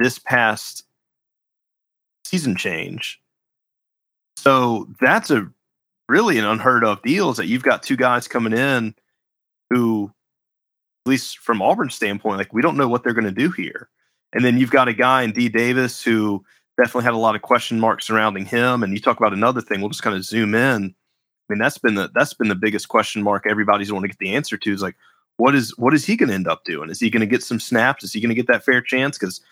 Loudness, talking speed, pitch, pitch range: -19 LUFS, 225 wpm, 115 Hz, 110-125 Hz